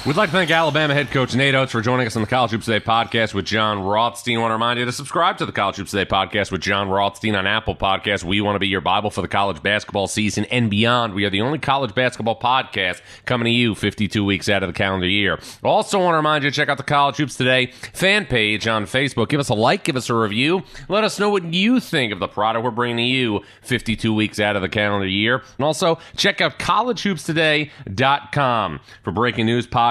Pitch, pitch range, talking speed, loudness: 115 Hz, 105-145 Hz, 245 wpm, -19 LUFS